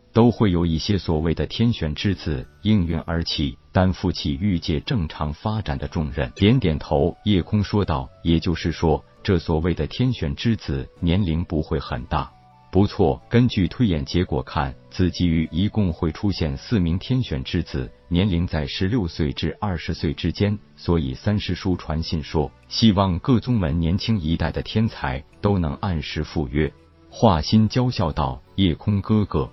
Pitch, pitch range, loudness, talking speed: 85 Hz, 75-100 Hz, -22 LUFS, 250 characters per minute